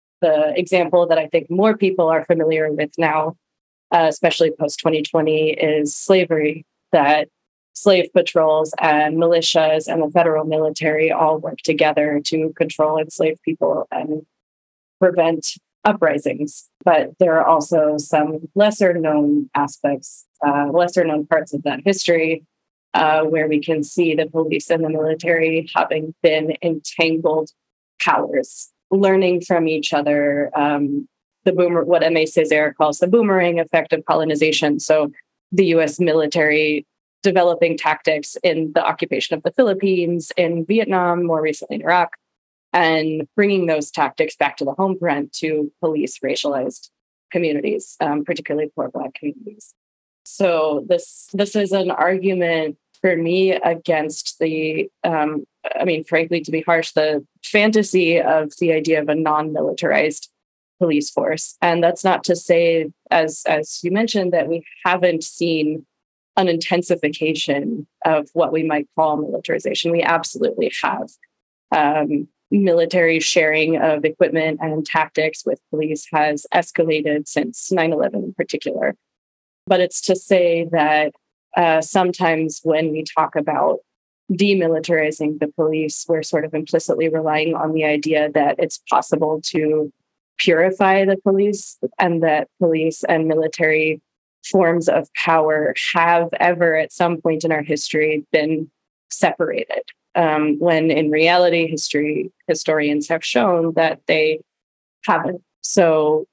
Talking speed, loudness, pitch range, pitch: 135 wpm, -18 LUFS, 155-175 Hz, 160 Hz